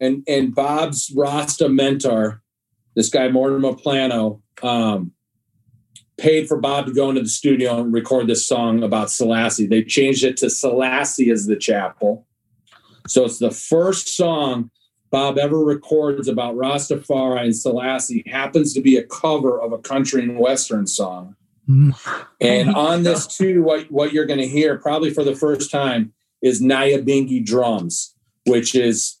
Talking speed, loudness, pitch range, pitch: 155 wpm, -18 LUFS, 115-145 Hz, 130 Hz